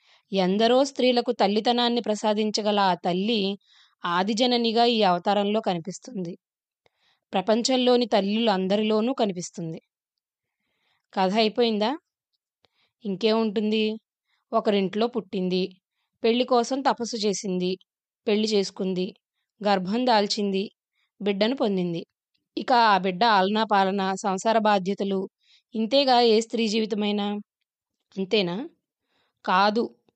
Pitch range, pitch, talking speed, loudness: 195-230 Hz, 215 Hz, 85 wpm, -24 LUFS